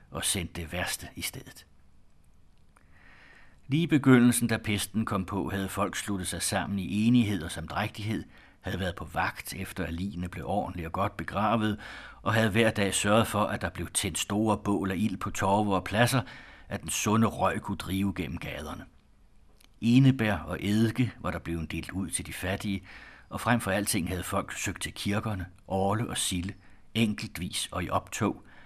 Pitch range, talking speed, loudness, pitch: 90-110 Hz, 180 wpm, -29 LUFS, 100 Hz